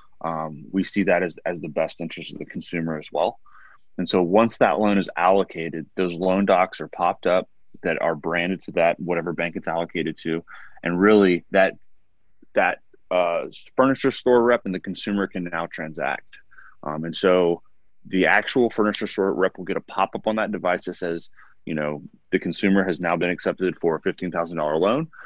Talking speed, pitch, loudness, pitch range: 195 wpm, 90 Hz, -23 LUFS, 85-100 Hz